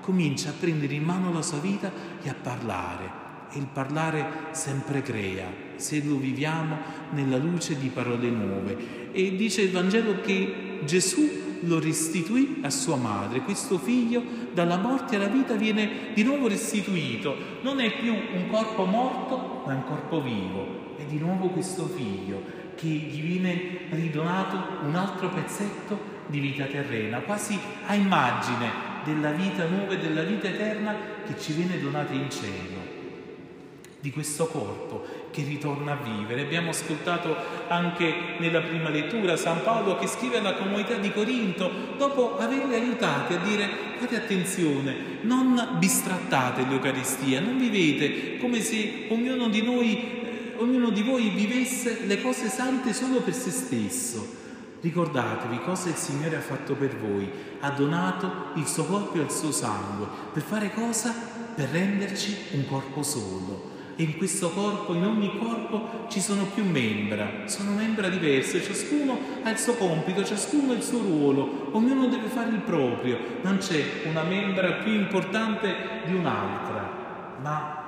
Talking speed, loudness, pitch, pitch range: 155 wpm, -27 LUFS, 185 Hz, 150-220 Hz